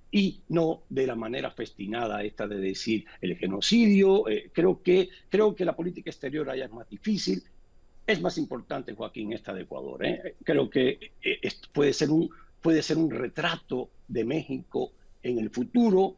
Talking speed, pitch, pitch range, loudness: 170 wpm, 155 Hz, 115-185 Hz, -28 LUFS